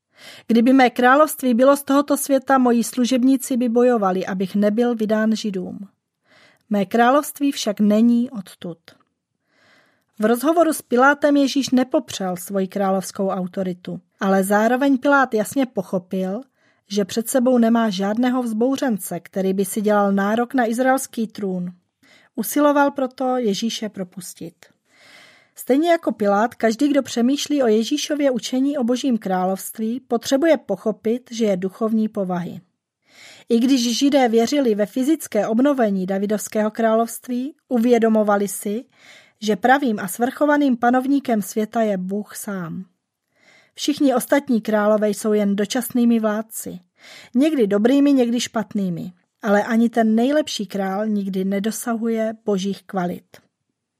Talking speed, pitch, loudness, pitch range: 120 wpm, 230 Hz, -19 LUFS, 205-260 Hz